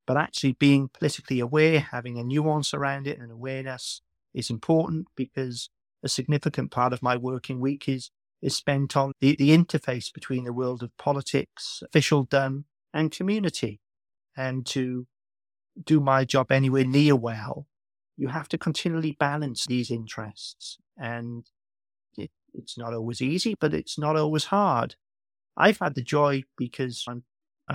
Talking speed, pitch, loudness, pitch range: 150 wpm, 135 Hz, -26 LUFS, 125-150 Hz